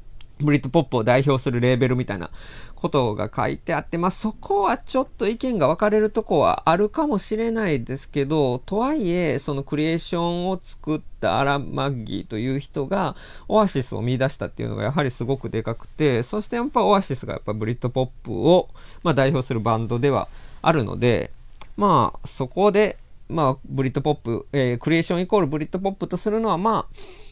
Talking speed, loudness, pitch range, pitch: 415 characters per minute, -22 LUFS, 130-190 Hz, 145 Hz